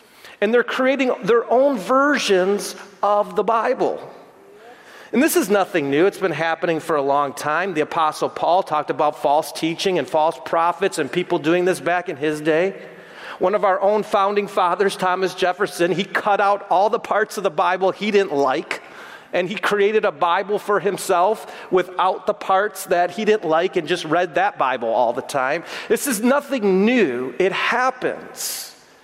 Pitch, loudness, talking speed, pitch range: 195 Hz, -20 LUFS, 180 wpm, 175-215 Hz